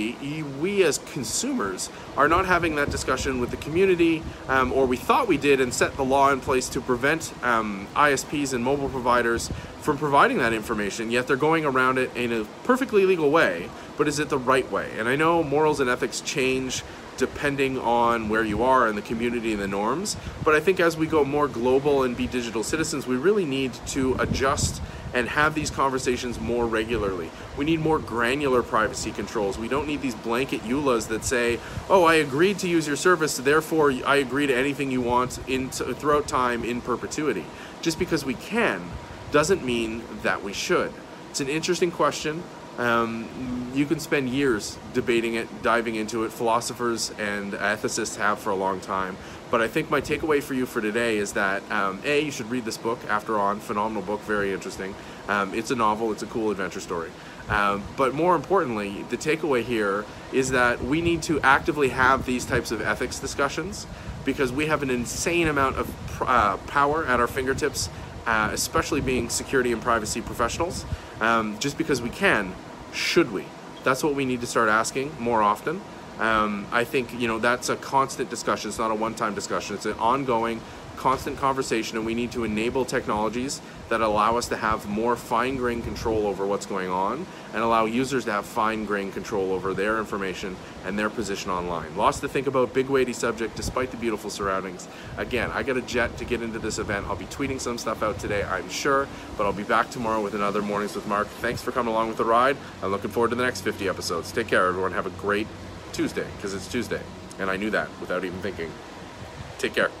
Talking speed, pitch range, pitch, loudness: 205 wpm, 110-140 Hz, 120 Hz, -25 LUFS